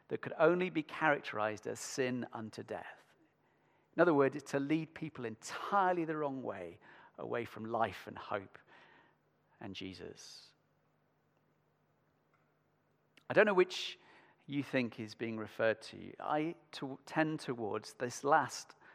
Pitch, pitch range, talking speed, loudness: 135 Hz, 115-155 Hz, 135 wpm, -36 LUFS